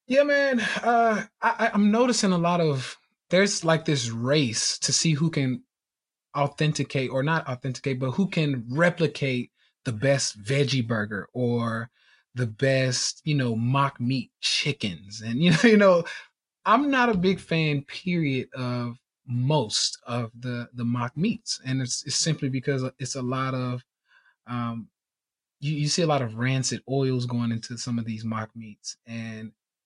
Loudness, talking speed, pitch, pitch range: -25 LUFS, 165 wpm, 135 Hz, 120-165 Hz